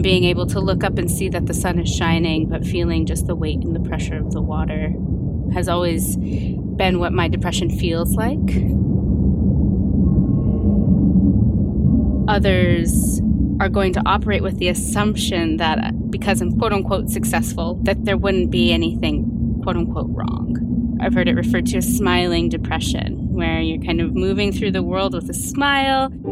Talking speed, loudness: 165 wpm, -19 LUFS